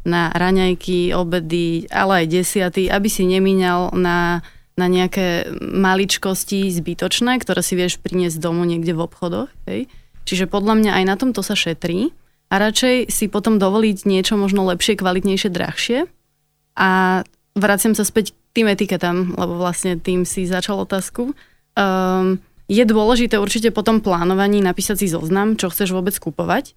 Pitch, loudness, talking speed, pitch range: 190 Hz, -18 LUFS, 150 wpm, 180-205 Hz